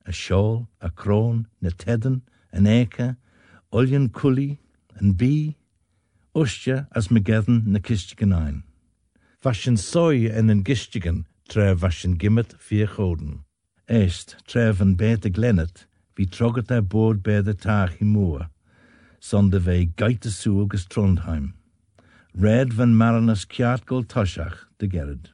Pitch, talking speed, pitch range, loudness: 105 Hz, 115 wpm, 95-115 Hz, -22 LUFS